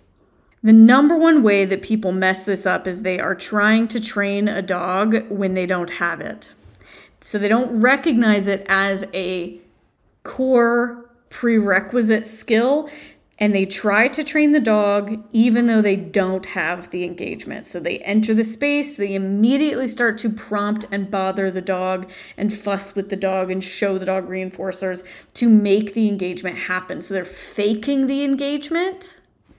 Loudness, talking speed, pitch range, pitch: -19 LUFS, 160 wpm, 190-235 Hz, 205 Hz